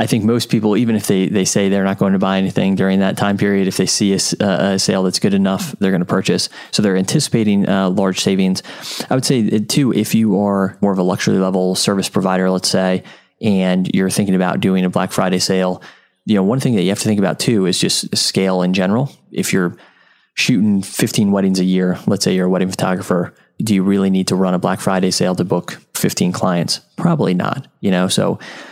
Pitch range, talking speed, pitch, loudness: 95-100 Hz, 235 wpm, 95 Hz, -16 LUFS